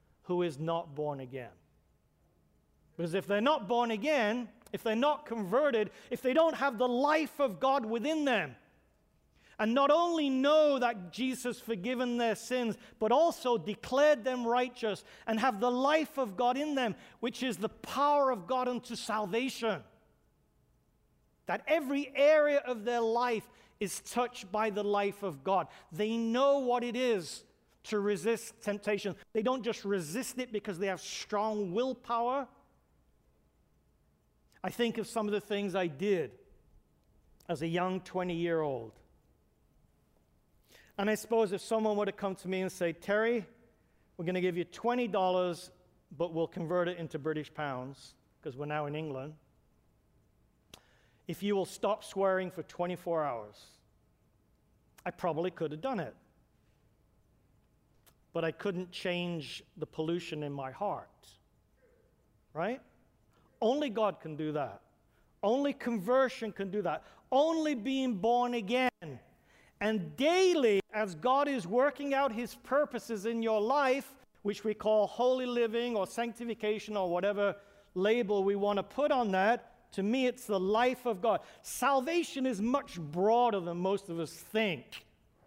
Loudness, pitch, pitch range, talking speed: -32 LUFS, 215 Hz, 185-250 Hz, 150 wpm